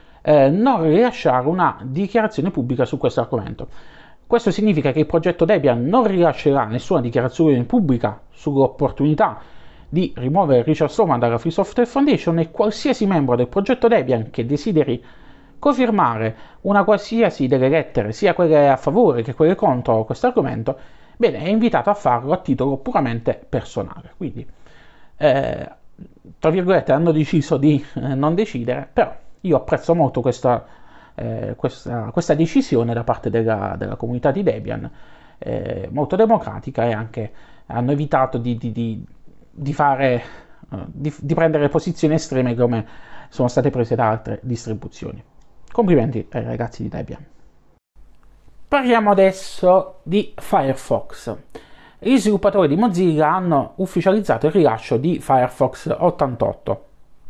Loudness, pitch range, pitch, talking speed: -19 LUFS, 125-185 Hz, 150 Hz, 135 wpm